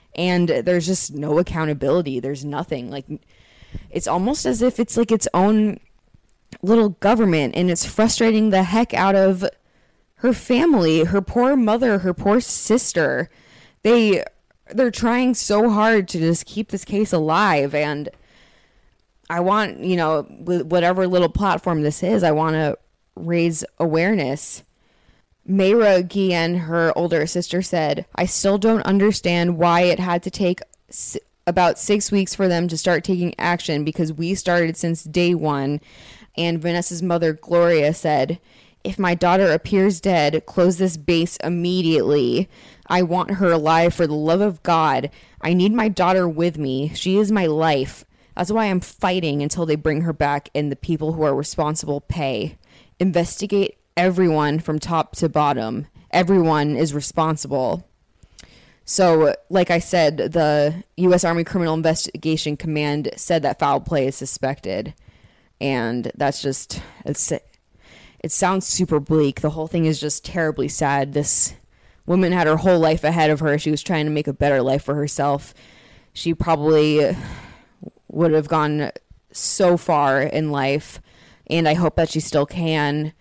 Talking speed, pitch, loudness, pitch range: 155 wpm, 170 Hz, -19 LUFS, 150-185 Hz